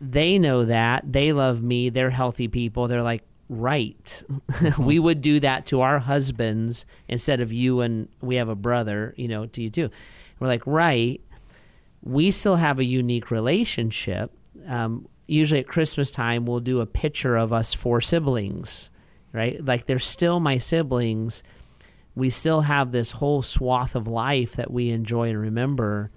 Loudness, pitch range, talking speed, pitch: -23 LUFS, 115-140 Hz, 170 wpm, 125 Hz